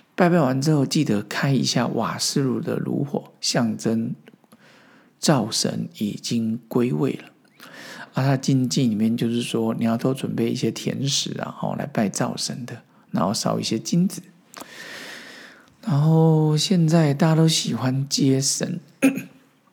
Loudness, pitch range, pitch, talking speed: -22 LUFS, 120-165 Hz, 140 Hz, 205 characters per minute